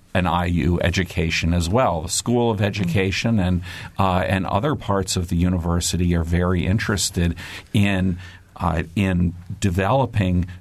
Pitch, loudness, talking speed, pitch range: 95 Hz, -21 LUFS, 135 wpm, 85-100 Hz